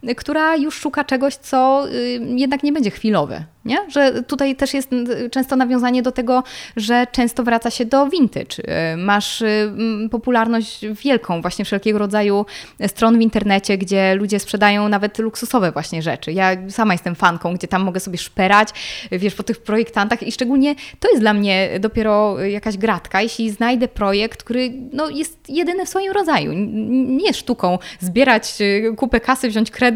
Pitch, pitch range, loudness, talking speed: 225 Hz, 205-260 Hz, -18 LUFS, 160 wpm